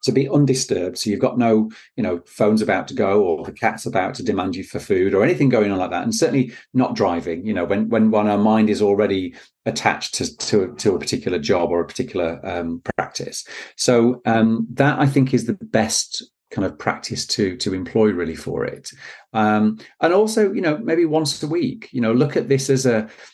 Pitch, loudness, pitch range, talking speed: 110 Hz, -20 LUFS, 105-135 Hz, 220 wpm